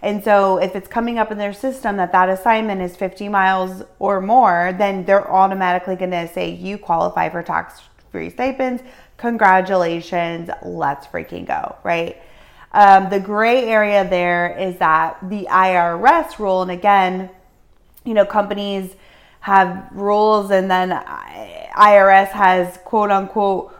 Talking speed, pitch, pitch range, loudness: 145 wpm, 195 Hz, 185-210 Hz, -16 LUFS